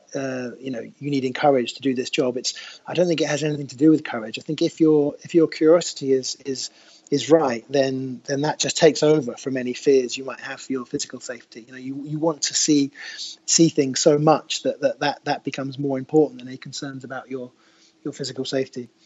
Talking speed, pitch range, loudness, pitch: 235 wpm, 130-150 Hz, -22 LUFS, 140 Hz